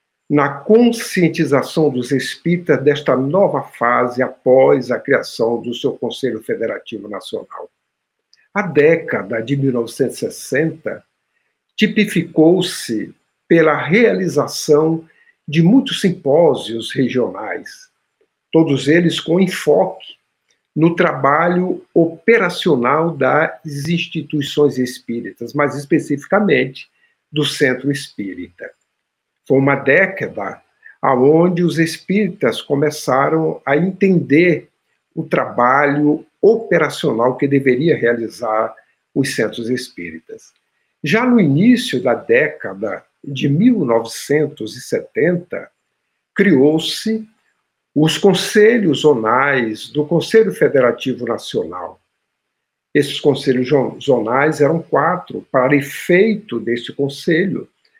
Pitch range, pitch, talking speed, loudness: 140-185 Hz, 155 Hz, 85 wpm, -16 LUFS